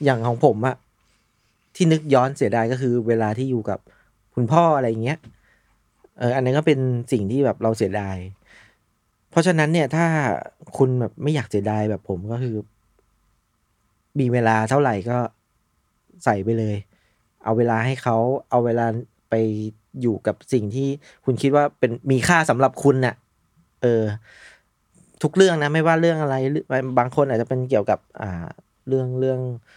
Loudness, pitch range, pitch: -21 LUFS, 110-135 Hz, 120 Hz